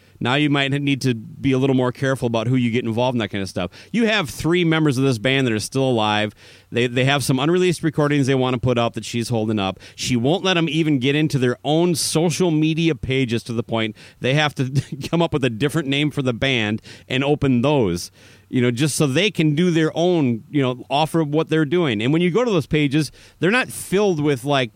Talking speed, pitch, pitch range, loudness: 250 wpm, 135 Hz, 120-155 Hz, -20 LUFS